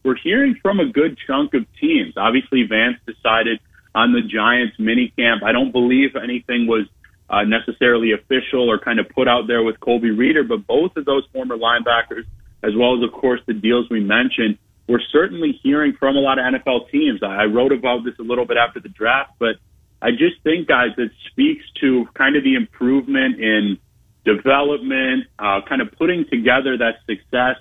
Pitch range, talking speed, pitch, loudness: 115-135 Hz, 195 wpm, 125 Hz, -18 LUFS